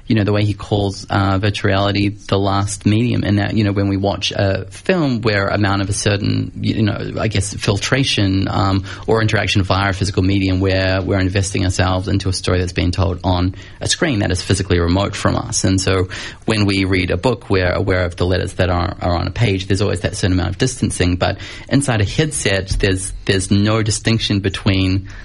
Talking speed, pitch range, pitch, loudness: 215 wpm, 95-105 Hz, 100 Hz, -17 LUFS